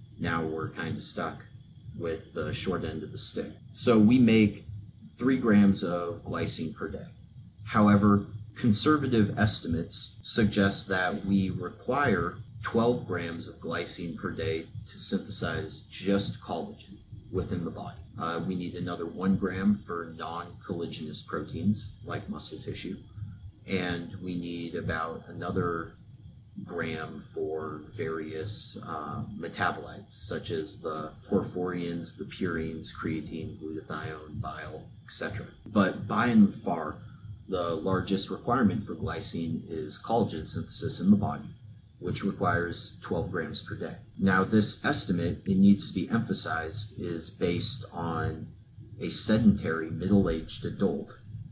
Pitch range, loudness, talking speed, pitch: 85-110 Hz, -29 LUFS, 130 wpm, 100 Hz